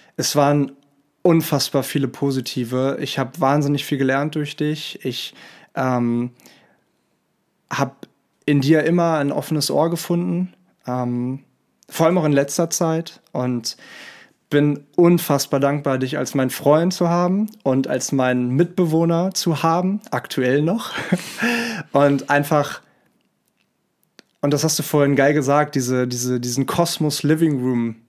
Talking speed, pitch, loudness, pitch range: 130 wpm, 145 Hz, -20 LUFS, 135-165 Hz